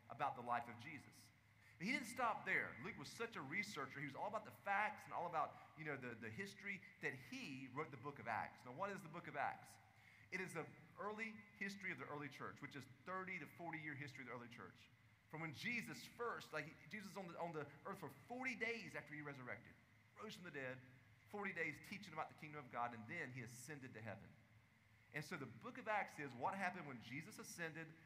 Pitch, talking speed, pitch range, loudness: 150 Hz, 235 wpm, 120-185 Hz, -49 LUFS